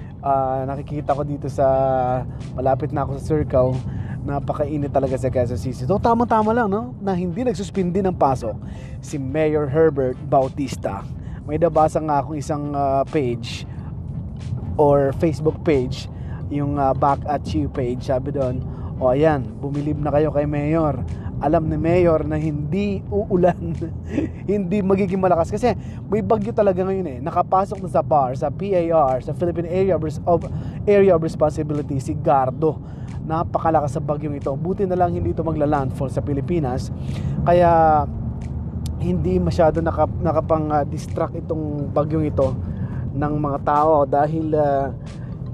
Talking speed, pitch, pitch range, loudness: 150 wpm, 150 Hz, 135-165 Hz, -21 LUFS